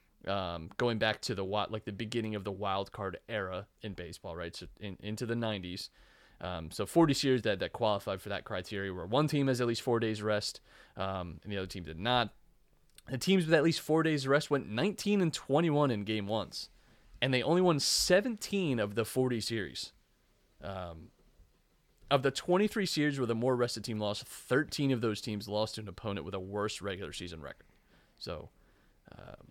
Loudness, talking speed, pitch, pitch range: -33 LUFS, 200 wpm, 110 Hz, 100-135 Hz